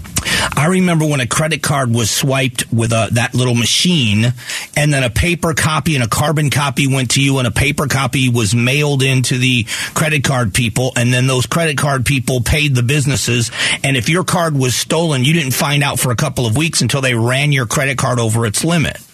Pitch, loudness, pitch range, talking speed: 135 Hz, -14 LUFS, 125-150 Hz, 215 wpm